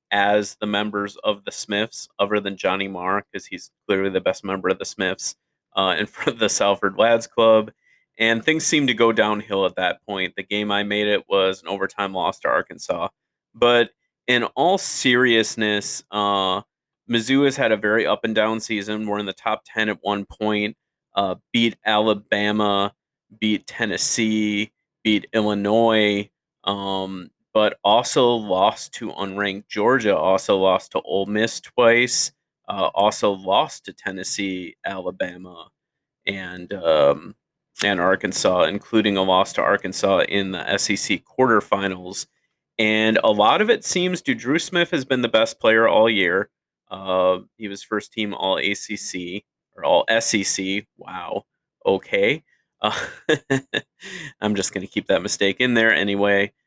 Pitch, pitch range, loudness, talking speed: 105 Hz, 100-115 Hz, -21 LUFS, 155 wpm